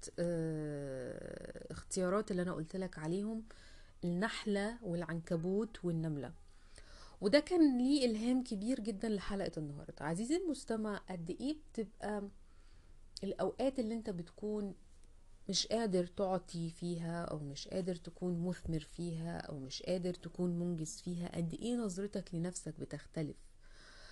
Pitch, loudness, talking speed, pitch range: 180 Hz, -39 LUFS, 115 wpm, 160-210 Hz